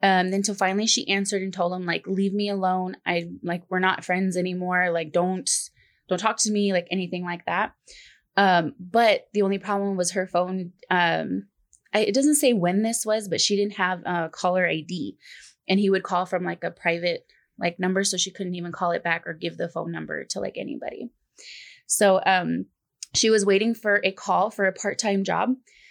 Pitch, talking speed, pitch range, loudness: 190 Hz, 210 wpm, 180-205 Hz, -24 LUFS